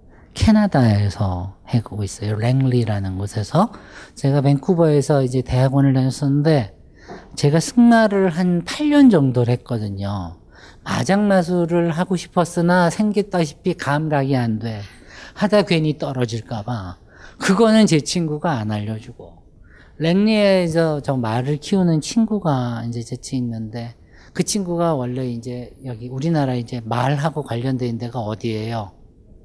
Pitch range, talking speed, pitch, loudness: 115-170 Hz, 290 characters per minute, 135 Hz, -19 LUFS